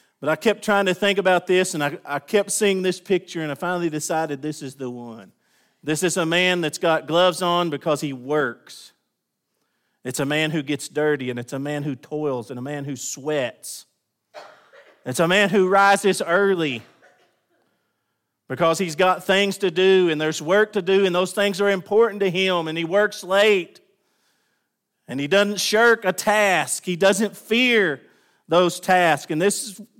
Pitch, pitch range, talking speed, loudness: 180 Hz, 150-195 Hz, 185 wpm, -20 LUFS